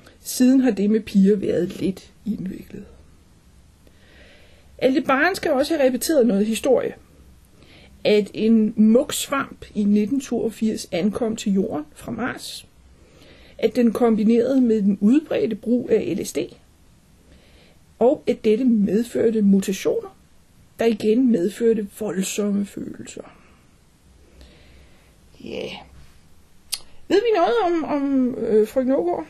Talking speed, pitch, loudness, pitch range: 110 wpm, 220 Hz, -20 LUFS, 185-250 Hz